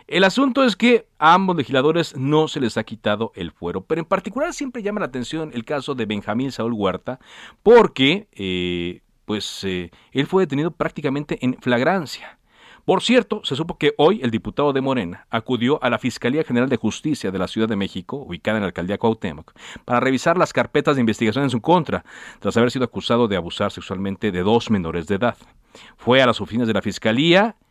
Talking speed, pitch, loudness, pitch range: 200 wpm, 125 Hz, -20 LUFS, 105-160 Hz